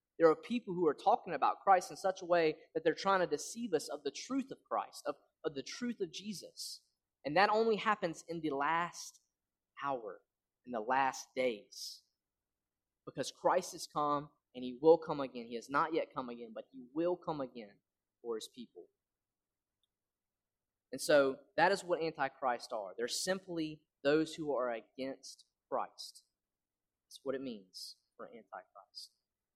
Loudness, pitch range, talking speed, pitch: -36 LUFS, 135-195 Hz, 170 wpm, 165 Hz